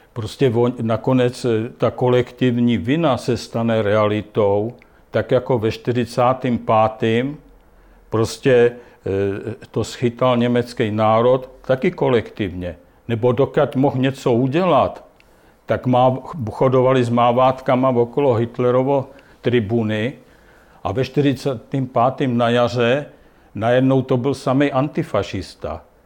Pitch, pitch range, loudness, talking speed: 125 Hz, 115-130 Hz, -18 LUFS, 95 wpm